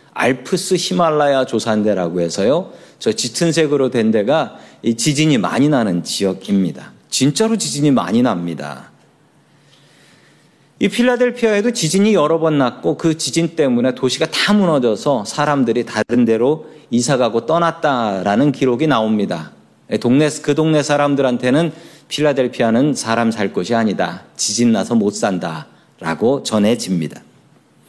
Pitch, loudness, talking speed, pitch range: 135 Hz, -16 LUFS, 305 characters per minute, 115-160 Hz